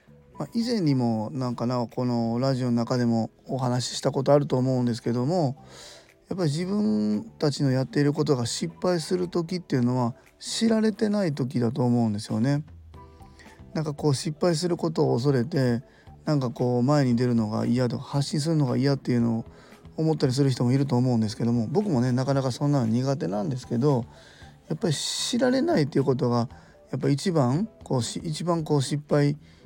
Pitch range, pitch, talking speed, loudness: 120-155 Hz, 135 Hz, 390 characters per minute, -25 LUFS